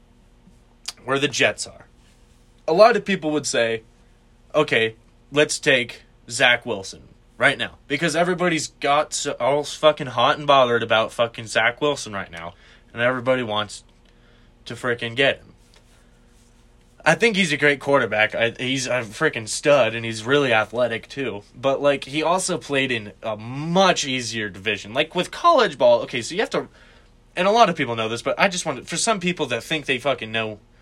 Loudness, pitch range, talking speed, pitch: -21 LUFS, 115-150 Hz, 185 wpm, 135 Hz